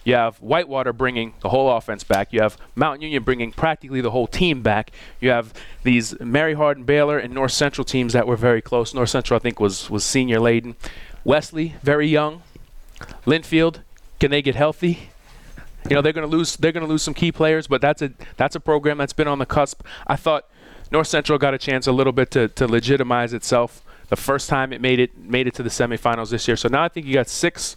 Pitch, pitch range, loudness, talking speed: 135 Hz, 120-150 Hz, -20 LUFS, 220 wpm